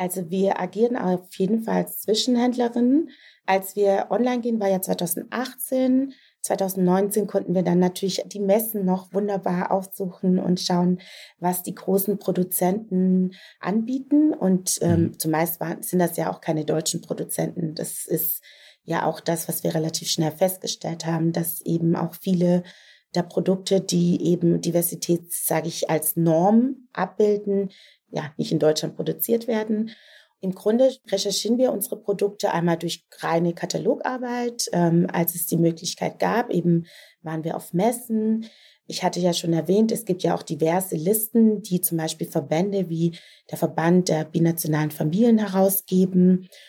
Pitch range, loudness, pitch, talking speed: 170-210 Hz, -23 LUFS, 185 Hz, 150 wpm